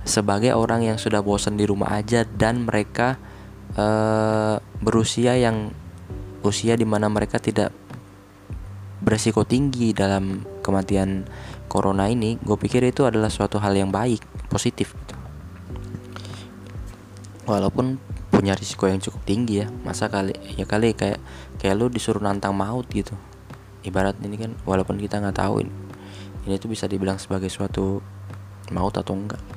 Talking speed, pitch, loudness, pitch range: 140 wpm, 100 Hz, -23 LUFS, 95-110 Hz